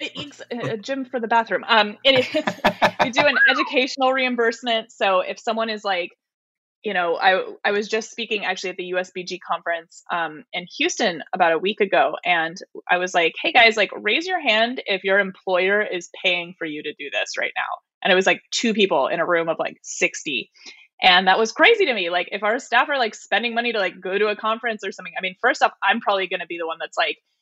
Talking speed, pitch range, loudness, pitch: 235 wpm, 180-235 Hz, -20 LUFS, 200 Hz